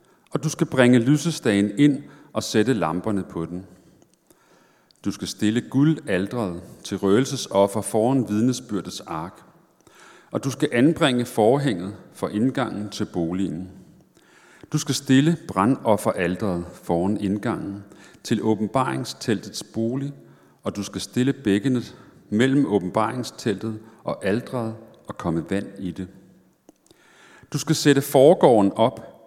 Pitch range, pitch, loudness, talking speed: 100-135 Hz, 110 Hz, -23 LUFS, 115 wpm